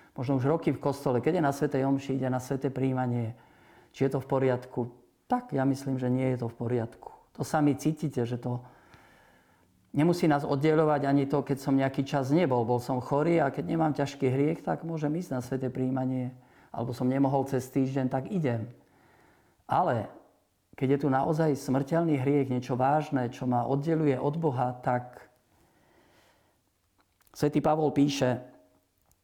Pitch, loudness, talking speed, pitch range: 135 Hz, -29 LUFS, 170 wpm, 125-145 Hz